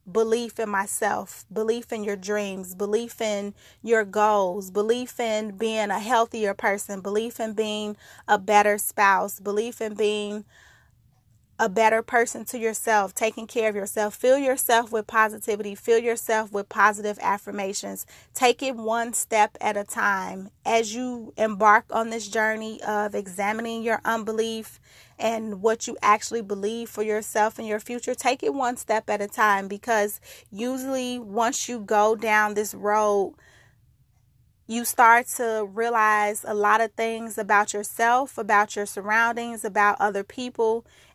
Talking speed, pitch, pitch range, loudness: 150 wpm, 220 Hz, 205-230 Hz, -24 LUFS